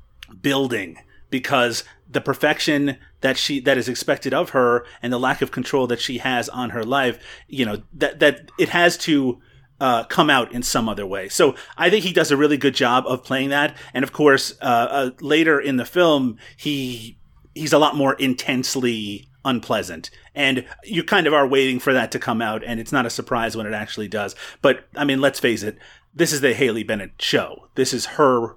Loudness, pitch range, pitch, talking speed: -20 LUFS, 120-145 Hz, 135 Hz, 210 wpm